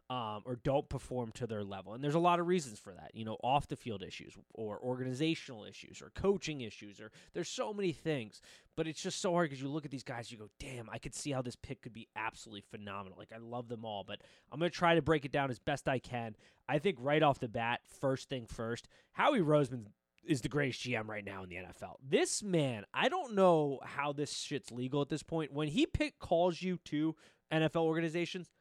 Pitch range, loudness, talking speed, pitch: 115-160 Hz, -36 LUFS, 235 wpm, 135 Hz